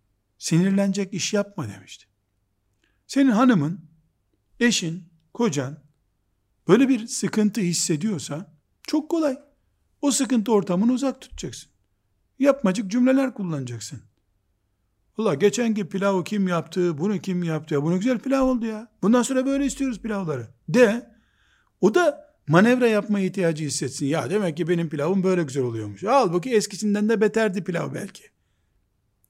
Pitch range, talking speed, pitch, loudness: 145-230 Hz, 125 wpm, 190 Hz, -23 LUFS